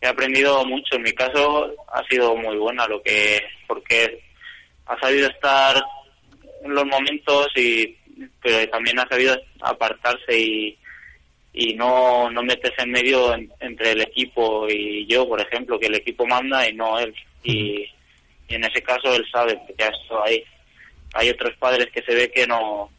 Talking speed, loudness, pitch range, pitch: 165 wpm, -20 LUFS, 110-130 Hz, 125 Hz